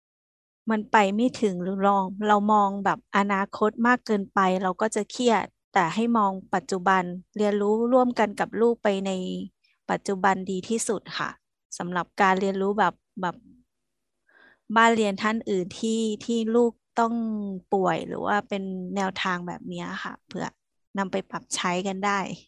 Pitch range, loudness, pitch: 190-220 Hz, -25 LUFS, 200 Hz